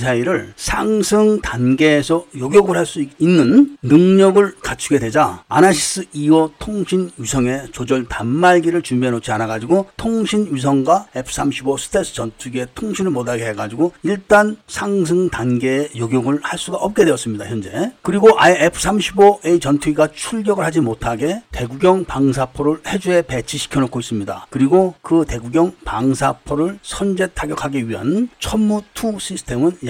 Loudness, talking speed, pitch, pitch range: -16 LUFS, 320 characters per minute, 155 Hz, 130-190 Hz